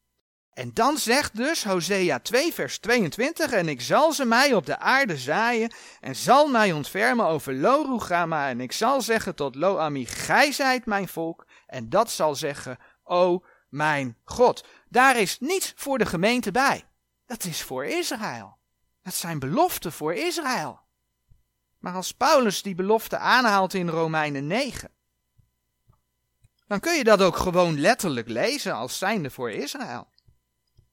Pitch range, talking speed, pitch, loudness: 155-250 Hz, 150 wpm, 195 Hz, -23 LUFS